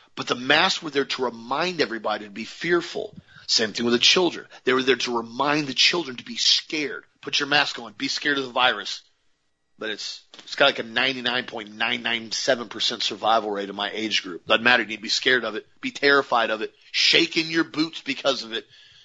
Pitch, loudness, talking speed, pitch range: 130 Hz, -22 LUFS, 215 wpm, 115-175 Hz